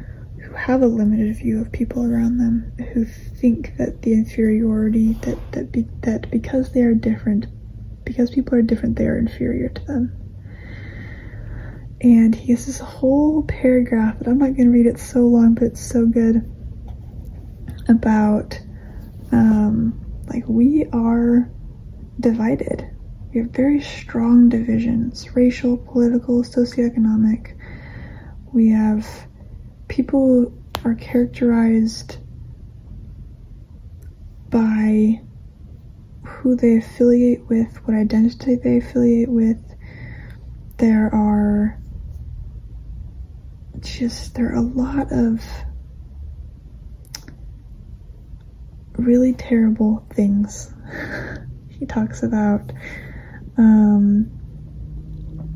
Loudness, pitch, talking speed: -18 LUFS, 225 Hz, 100 wpm